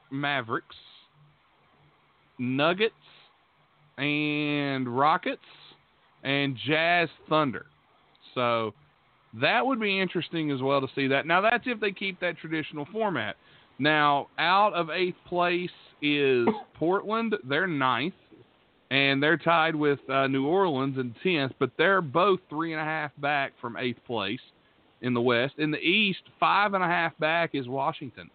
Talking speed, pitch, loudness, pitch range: 140 wpm, 150 Hz, -26 LUFS, 135-175 Hz